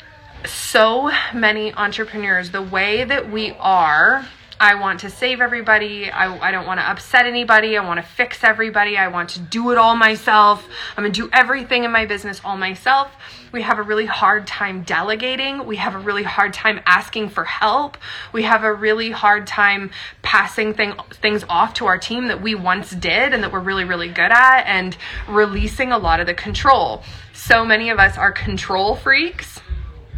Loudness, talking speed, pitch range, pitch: -16 LUFS, 190 wpm, 195-235 Hz, 215 Hz